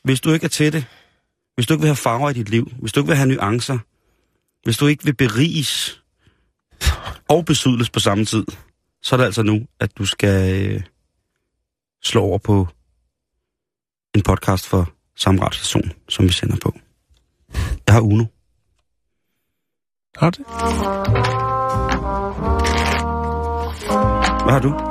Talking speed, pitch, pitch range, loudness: 140 wpm, 110 Hz, 95-130 Hz, -19 LUFS